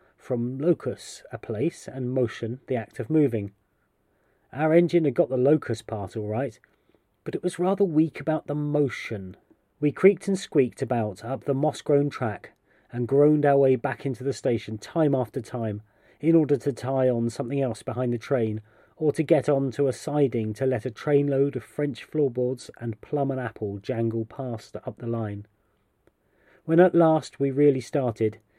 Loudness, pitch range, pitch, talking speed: -25 LUFS, 115-145 Hz, 130 Hz, 185 wpm